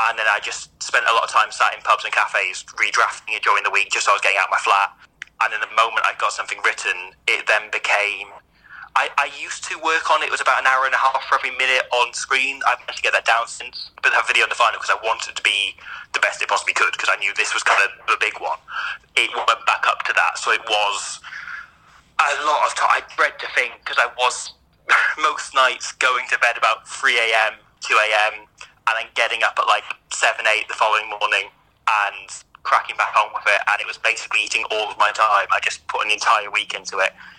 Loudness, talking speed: -19 LUFS, 255 wpm